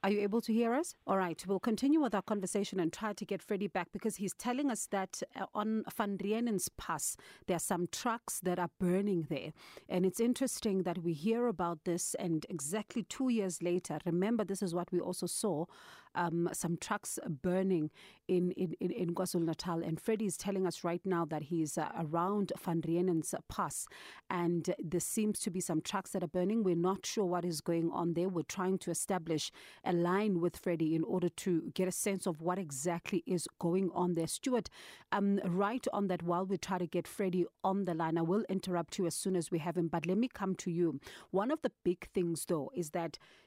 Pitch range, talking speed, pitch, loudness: 170-200 Hz, 220 wpm, 180 Hz, -35 LUFS